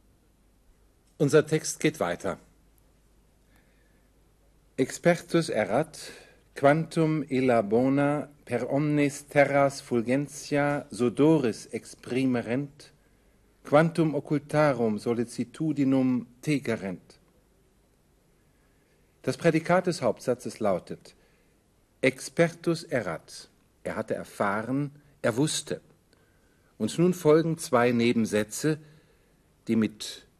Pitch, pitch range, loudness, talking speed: 140 Hz, 120-155 Hz, -27 LUFS, 75 wpm